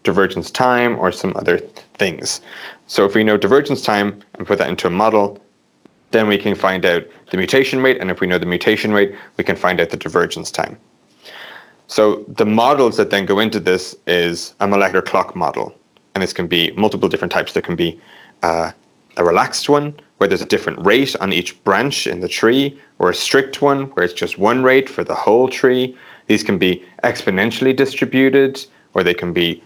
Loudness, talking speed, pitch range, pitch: -16 LUFS, 200 wpm, 90-130 Hz, 105 Hz